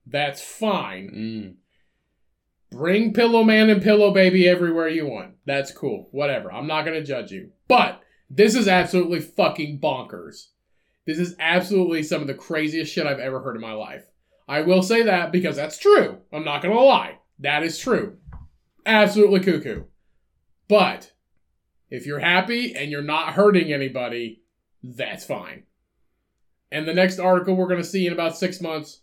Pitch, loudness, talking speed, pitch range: 160 Hz, -20 LUFS, 165 wpm, 135-185 Hz